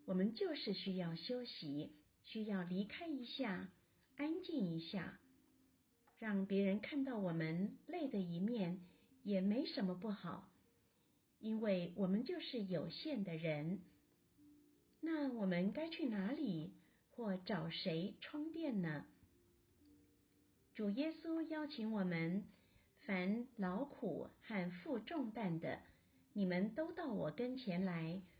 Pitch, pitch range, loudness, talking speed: 200 Hz, 175-260 Hz, -43 LUFS, 170 characters per minute